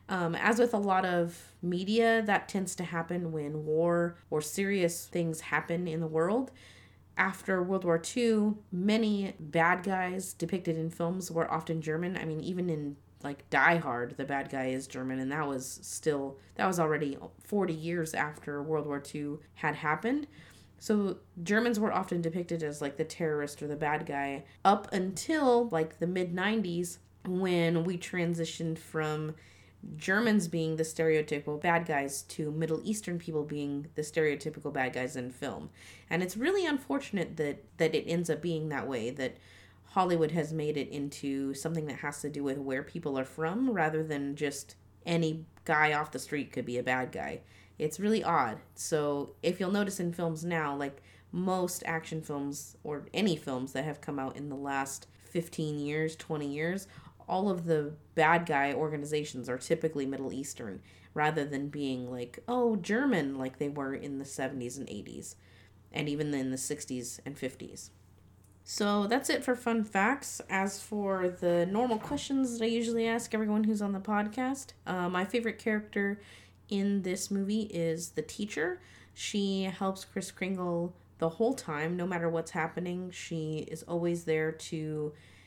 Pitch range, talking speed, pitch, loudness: 145-190 Hz, 175 wpm, 160 Hz, -32 LUFS